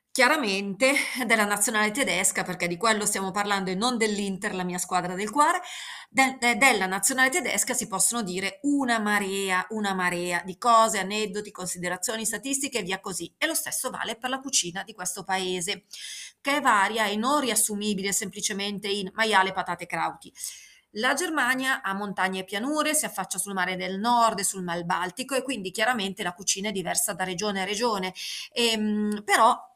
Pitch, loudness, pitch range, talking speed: 205 Hz, -25 LUFS, 190-240 Hz, 175 wpm